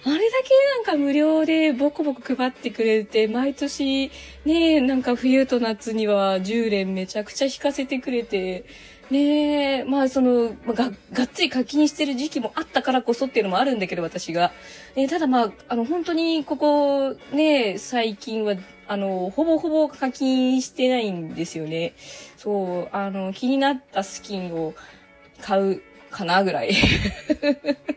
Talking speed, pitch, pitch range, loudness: 290 characters per minute, 260 Hz, 210-290 Hz, -22 LUFS